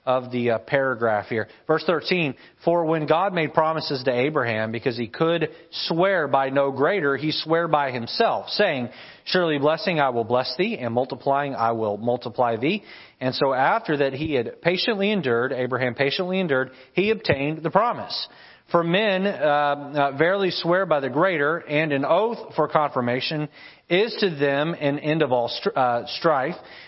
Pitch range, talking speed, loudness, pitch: 130-170 Hz, 170 wpm, -23 LUFS, 150 Hz